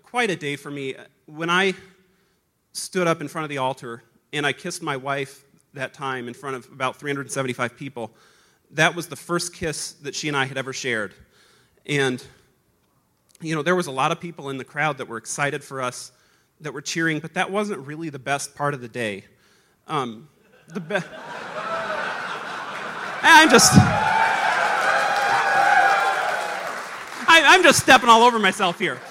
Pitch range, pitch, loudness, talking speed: 135-175 Hz, 145 Hz, -20 LUFS, 170 wpm